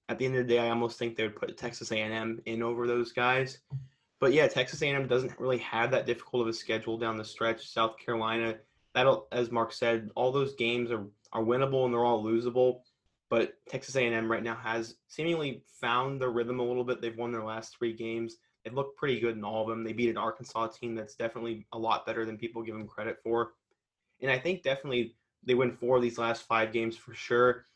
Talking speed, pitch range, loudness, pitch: 230 wpm, 115-125 Hz, -31 LUFS, 115 Hz